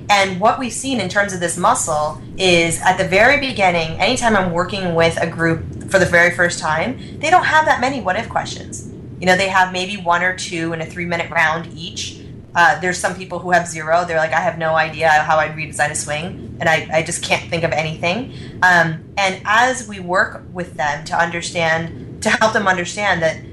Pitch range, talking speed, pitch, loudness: 160-190 Hz, 220 wpm, 170 Hz, -17 LUFS